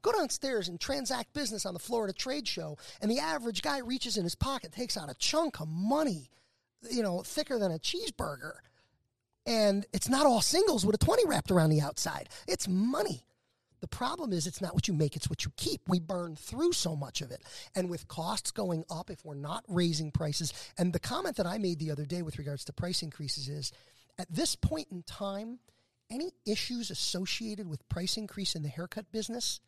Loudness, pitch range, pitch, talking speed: -33 LUFS, 155-230 Hz, 185 Hz, 210 wpm